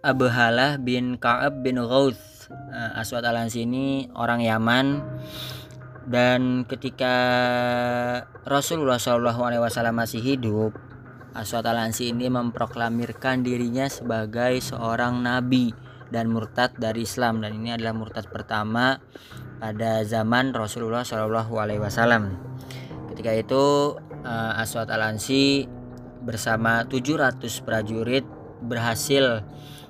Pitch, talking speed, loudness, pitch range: 120 Hz, 90 wpm, -24 LUFS, 115-130 Hz